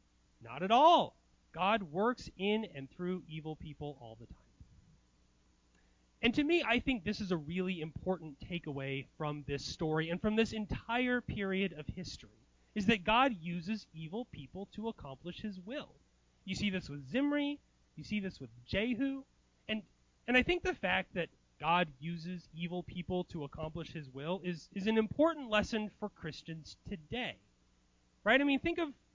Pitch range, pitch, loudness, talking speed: 150-220 Hz, 180 Hz, -35 LUFS, 170 wpm